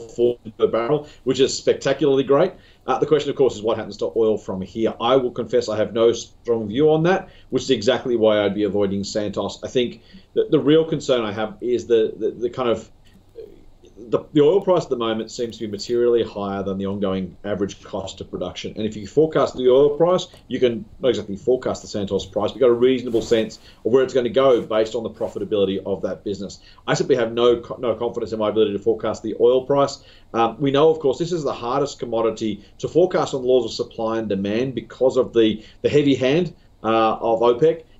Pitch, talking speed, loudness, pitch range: 120 Hz, 225 wpm, -21 LUFS, 110-140 Hz